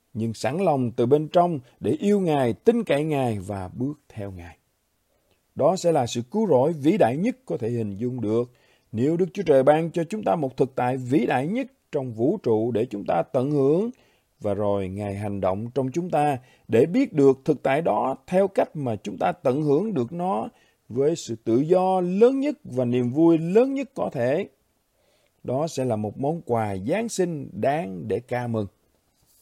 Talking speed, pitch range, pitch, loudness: 205 wpm, 115-170 Hz, 135 Hz, -24 LUFS